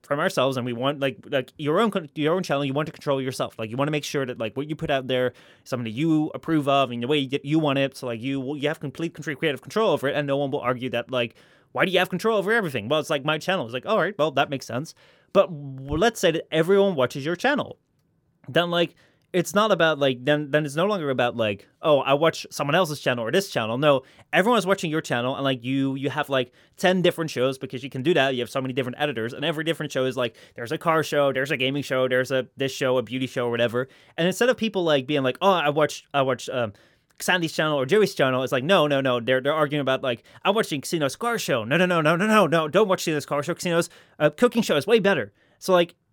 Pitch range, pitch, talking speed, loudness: 130-170 Hz, 145 Hz, 280 wpm, -24 LUFS